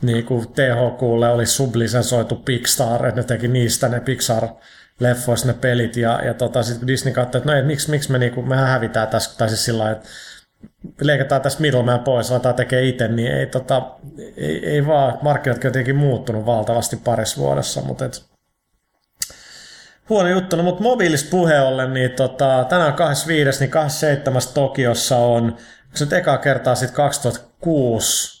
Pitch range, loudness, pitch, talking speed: 120-140 Hz, -18 LUFS, 125 Hz, 165 wpm